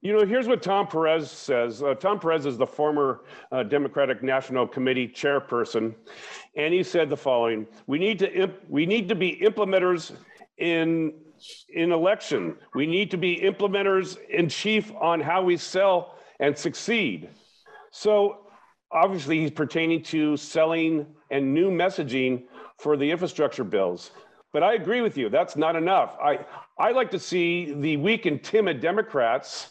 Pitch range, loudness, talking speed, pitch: 150-195 Hz, -25 LUFS, 160 wpm, 165 Hz